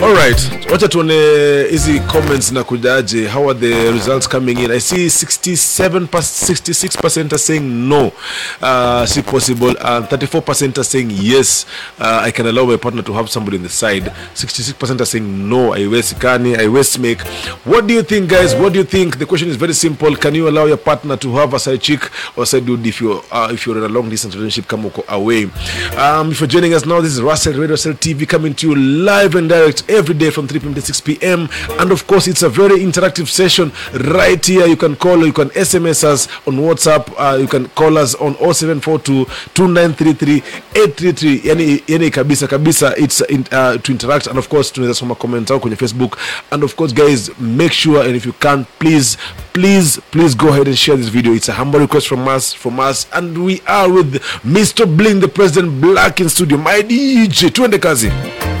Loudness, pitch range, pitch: -12 LUFS, 125-165 Hz, 145 Hz